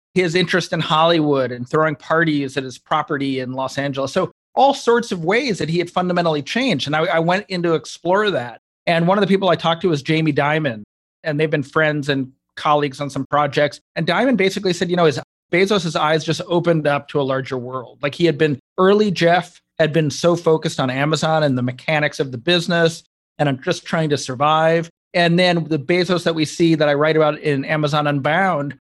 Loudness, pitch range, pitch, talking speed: -18 LUFS, 145-175 Hz, 160 Hz, 220 wpm